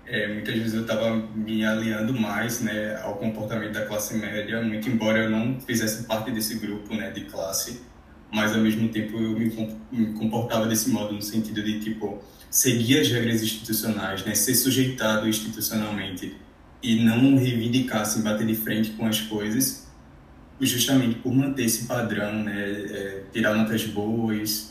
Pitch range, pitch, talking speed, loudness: 105-115 Hz, 110 Hz, 160 wpm, -25 LUFS